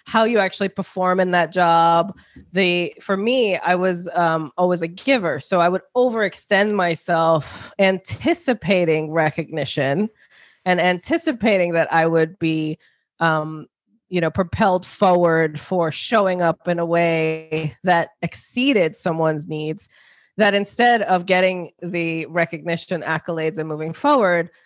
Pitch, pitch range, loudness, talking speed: 175 Hz, 165-195 Hz, -19 LUFS, 130 wpm